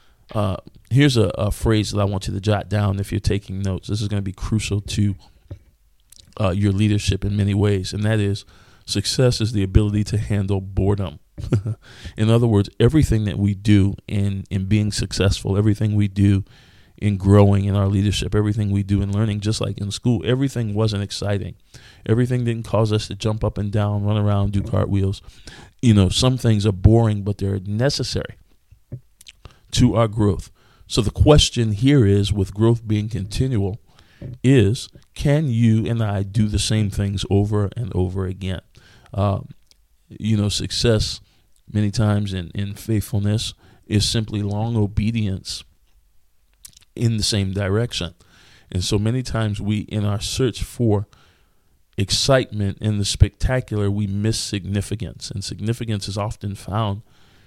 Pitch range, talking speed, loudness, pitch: 100-110 Hz, 160 wpm, -20 LUFS, 105 Hz